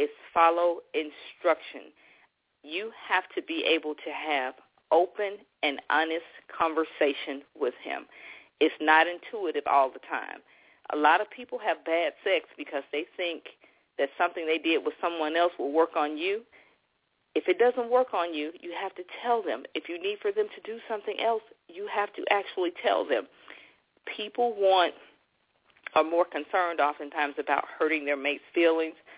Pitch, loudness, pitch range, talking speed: 175 Hz, -28 LUFS, 155-240 Hz, 165 wpm